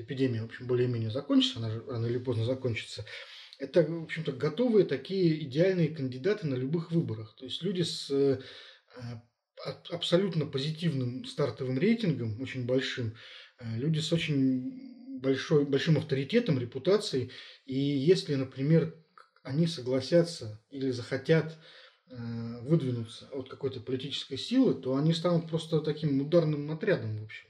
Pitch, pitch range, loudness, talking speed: 135 Hz, 125-165 Hz, -30 LUFS, 130 wpm